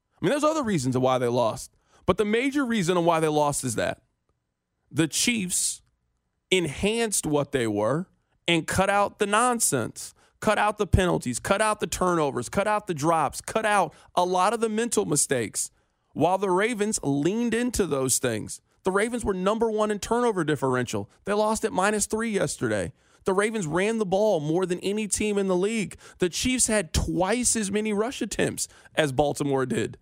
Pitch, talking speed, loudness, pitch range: 195 Hz, 185 wpm, -25 LUFS, 155-215 Hz